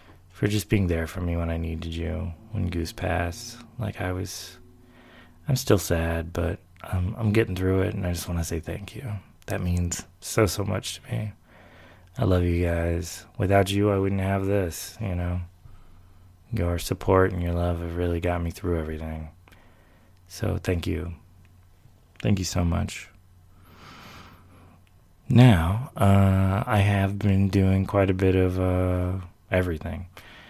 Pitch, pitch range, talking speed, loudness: 90 Hz, 85-100 Hz, 160 wpm, -25 LUFS